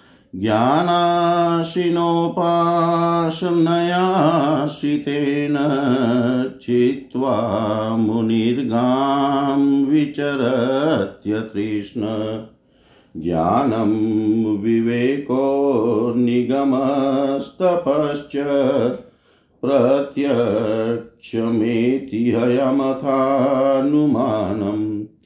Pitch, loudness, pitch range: 135 Hz, -19 LUFS, 115-145 Hz